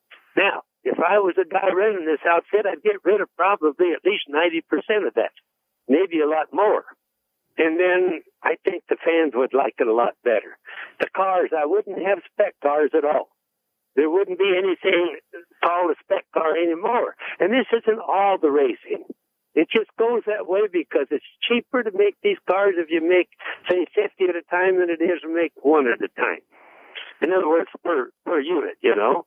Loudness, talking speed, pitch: -21 LUFS, 200 wpm, 200 Hz